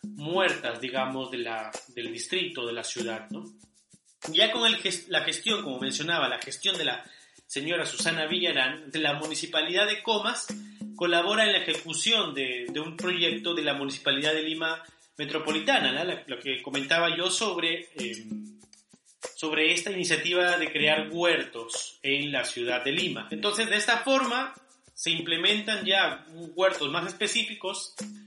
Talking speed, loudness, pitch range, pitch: 155 wpm, -26 LUFS, 145-205 Hz, 165 Hz